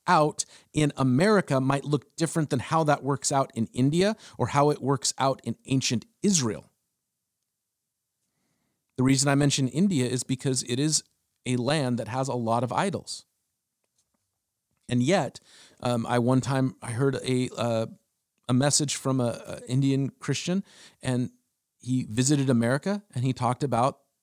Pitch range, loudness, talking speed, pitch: 125-145 Hz, -26 LUFS, 155 wpm, 135 Hz